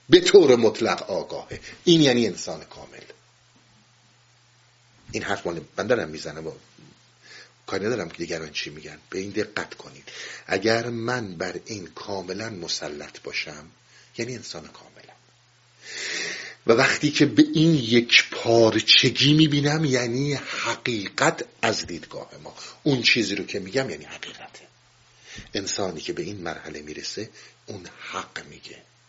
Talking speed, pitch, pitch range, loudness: 130 wpm, 120 Hz, 110-145 Hz, -22 LUFS